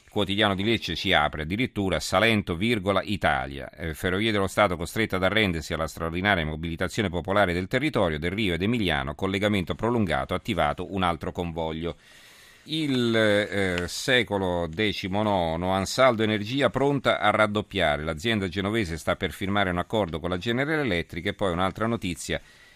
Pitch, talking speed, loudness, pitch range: 95 Hz, 150 wpm, -25 LUFS, 85-110 Hz